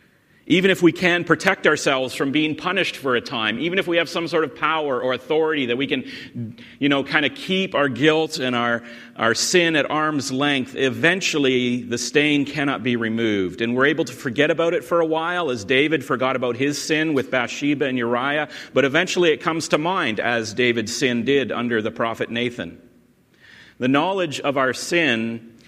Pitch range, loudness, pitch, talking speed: 120-160 Hz, -20 LUFS, 140 Hz, 195 wpm